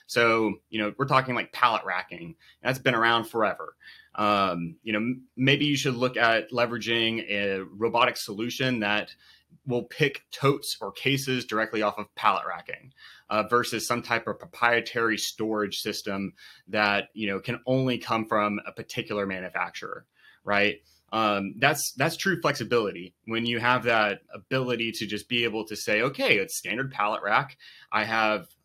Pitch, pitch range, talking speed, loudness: 115 Hz, 105-125 Hz, 160 wpm, -26 LUFS